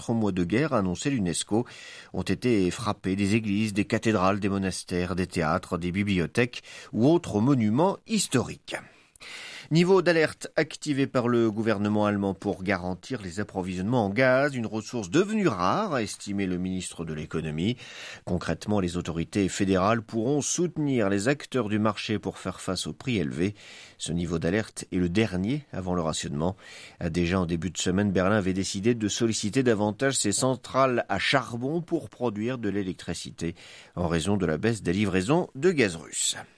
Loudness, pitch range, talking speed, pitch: -27 LUFS, 90-120 Hz, 160 wpm, 105 Hz